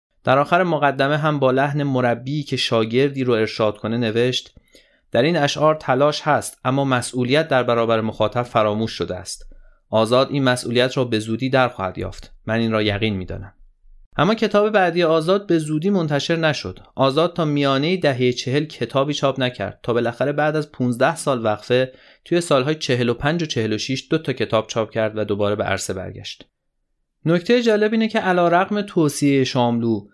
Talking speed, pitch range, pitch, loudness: 175 wpm, 115-155 Hz, 130 Hz, -20 LUFS